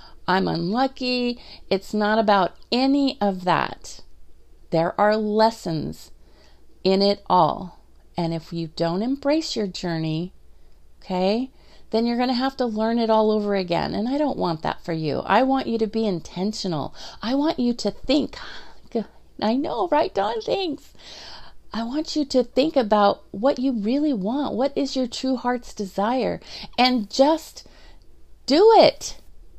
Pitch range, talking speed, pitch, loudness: 185-260 Hz, 155 wpm, 220 Hz, -22 LUFS